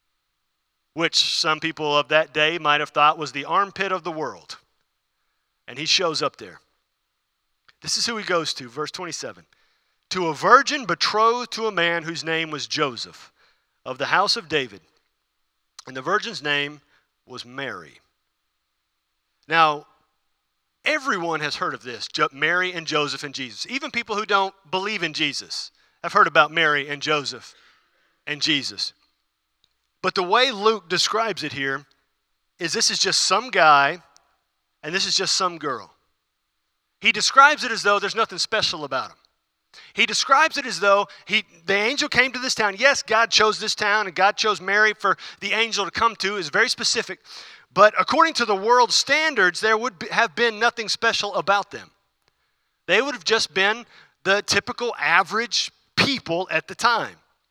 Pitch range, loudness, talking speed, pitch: 155-225 Hz, -21 LUFS, 170 wpm, 195 Hz